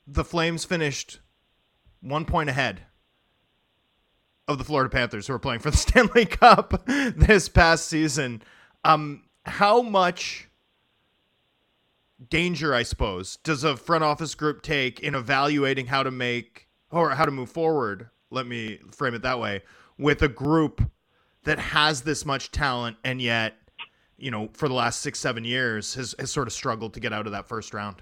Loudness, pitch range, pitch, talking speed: -24 LUFS, 120-155 Hz, 135 Hz, 165 wpm